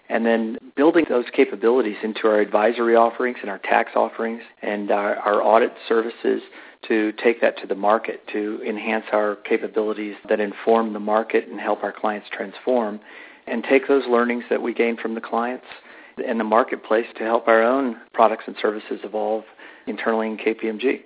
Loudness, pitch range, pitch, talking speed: -21 LUFS, 110-115 Hz, 115 Hz, 175 wpm